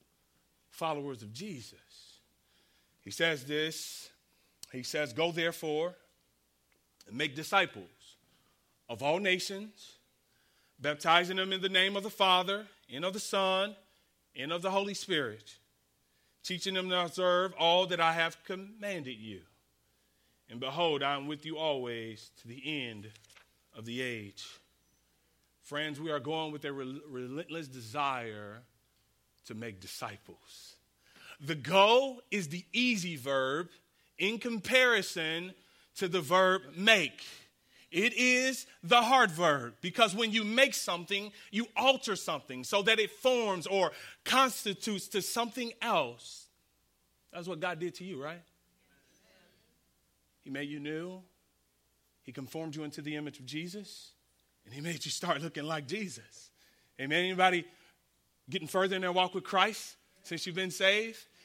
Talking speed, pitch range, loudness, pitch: 140 wpm, 120-190 Hz, -31 LUFS, 165 Hz